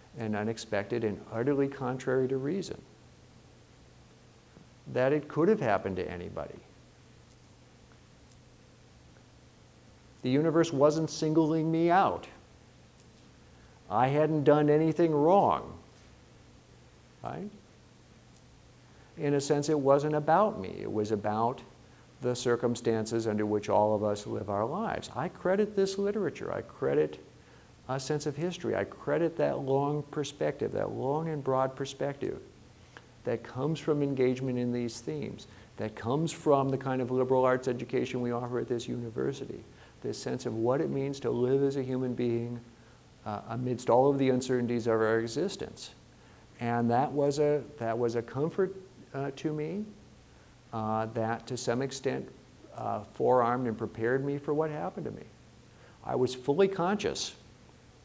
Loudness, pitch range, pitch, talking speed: -30 LUFS, 115-150 Hz, 130 Hz, 145 wpm